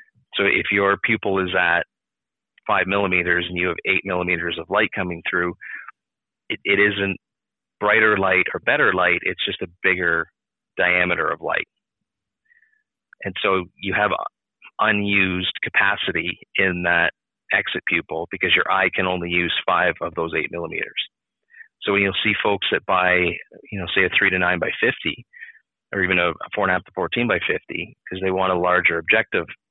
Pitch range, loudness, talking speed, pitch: 90-100 Hz, -20 LUFS, 175 wpm, 95 Hz